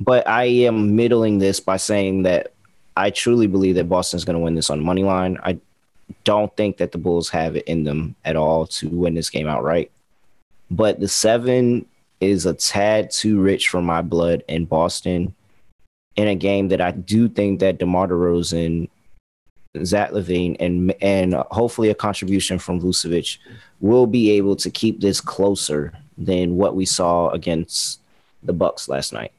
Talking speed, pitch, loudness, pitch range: 175 wpm, 95 Hz, -19 LUFS, 85-105 Hz